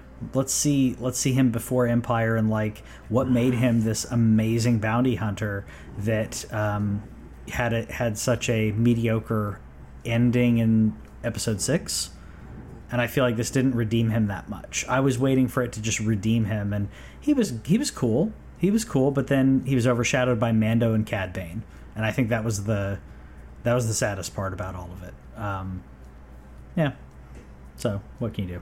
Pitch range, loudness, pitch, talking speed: 100-125 Hz, -25 LUFS, 115 Hz, 180 wpm